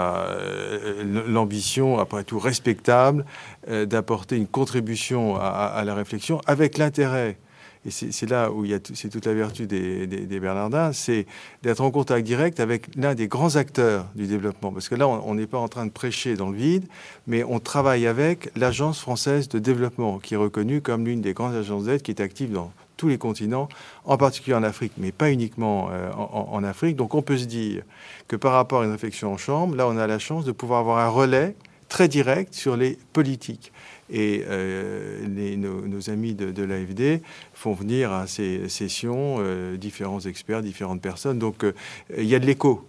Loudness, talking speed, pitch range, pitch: -24 LUFS, 205 wpm, 105-135 Hz, 115 Hz